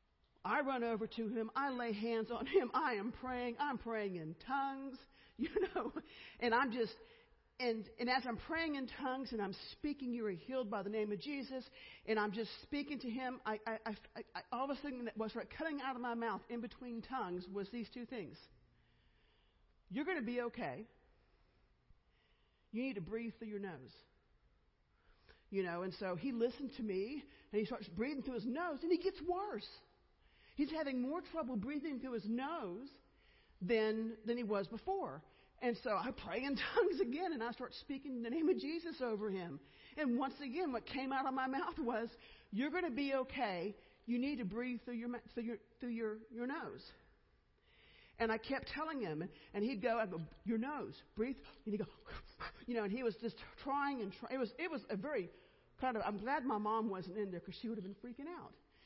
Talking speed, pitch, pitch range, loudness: 210 wpm, 240 Hz, 220-275 Hz, -42 LUFS